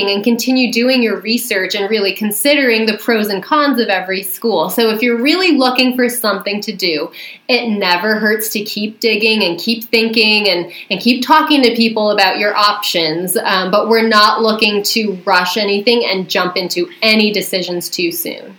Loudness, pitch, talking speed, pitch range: -13 LUFS, 215 Hz, 185 wpm, 195-230 Hz